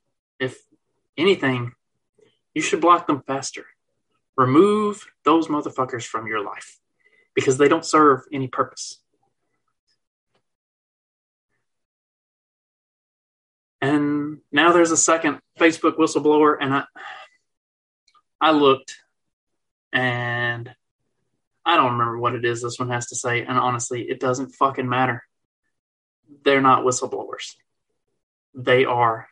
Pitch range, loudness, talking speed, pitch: 120-160 Hz, -20 LUFS, 110 wpm, 135 Hz